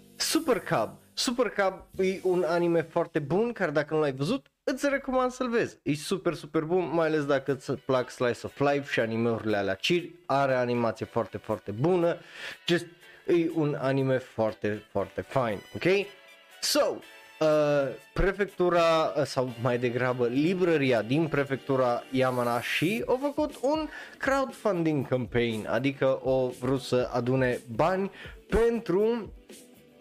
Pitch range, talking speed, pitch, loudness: 125-185 Hz, 140 wpm, 155 Hz, -28 LUFS